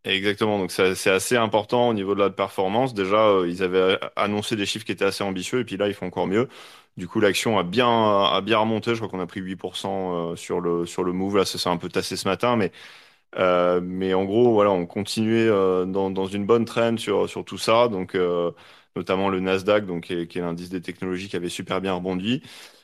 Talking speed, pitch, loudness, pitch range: 240 wpm, 95 Hz, -23 LUFS, 90-105 Hz